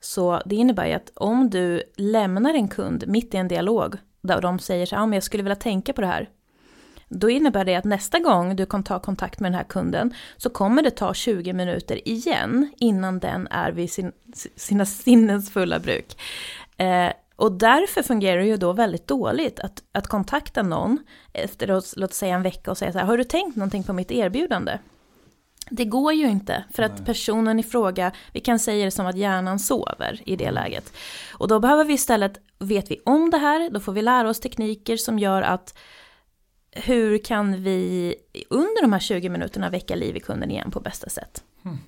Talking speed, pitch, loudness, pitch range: 205 wpm, 210 Hz, -23 LUFS, 185-240 Hz